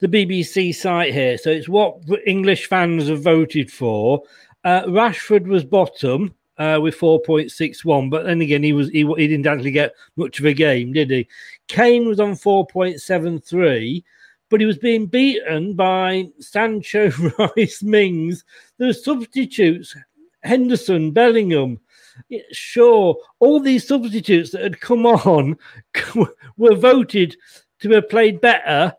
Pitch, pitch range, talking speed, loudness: 185 Hz, 160-225 Hz, 135 wpm, -17 LUFS